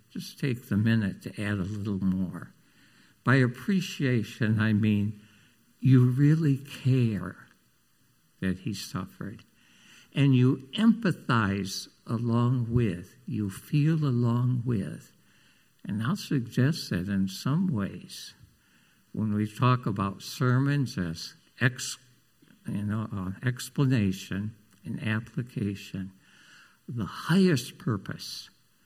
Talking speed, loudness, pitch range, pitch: 105 wpm, -28 LUFS, 100-135 Hz, 120 Hz